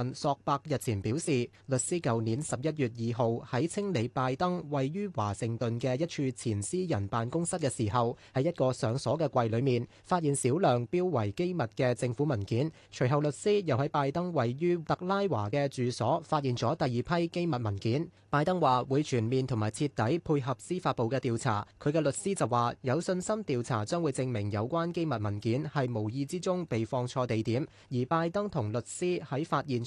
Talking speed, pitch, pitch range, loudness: 285 characters per minute, 130 Hz, 120-160 Hz, -31 LUFS